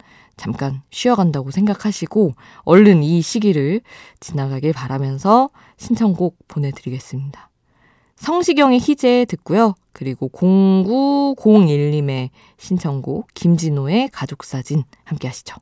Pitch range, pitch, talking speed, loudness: 135-210 Hz, 170 Hz, 255 characters per minute, -17 LUFS